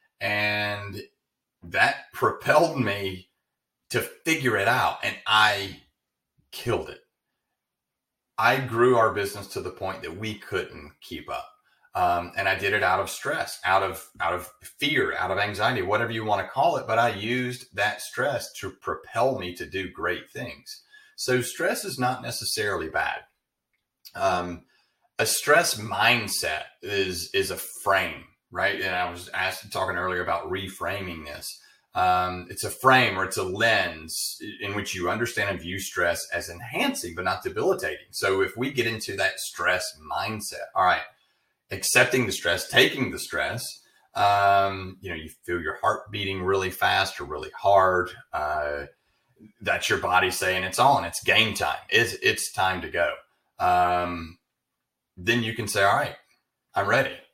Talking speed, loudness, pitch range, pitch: 160 wpm, -25 LUFS, 90-115 Hz, 100 Hz